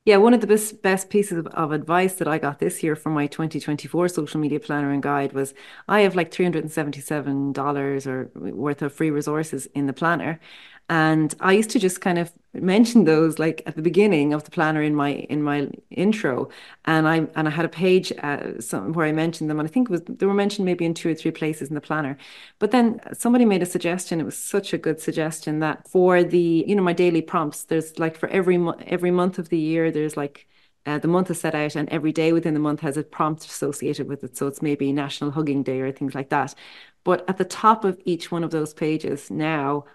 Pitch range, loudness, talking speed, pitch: 150-180 Hz, -22 LUFS, 245 wpm, 160 Hz